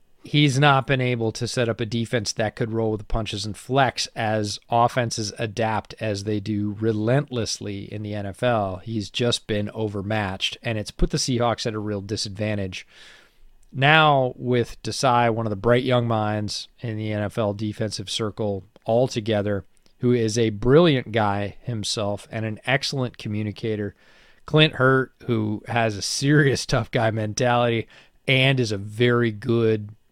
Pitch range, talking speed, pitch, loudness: 105-125 Hz, 155 wpm, 115 Hz, -23 LUFS